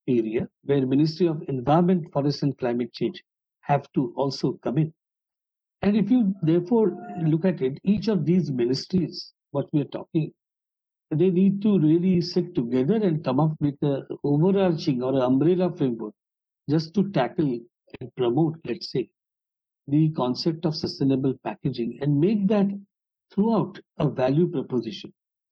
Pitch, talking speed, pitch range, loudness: 155 Hz, 150 wpm, 135-180 Hz, -24 LUFS